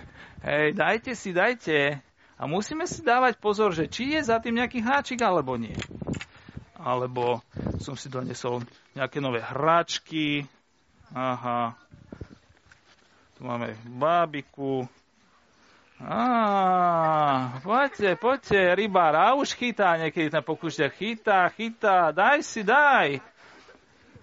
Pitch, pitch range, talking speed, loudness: 160 Hz, 130-220 Hz, 105 wpm, -25 LUFS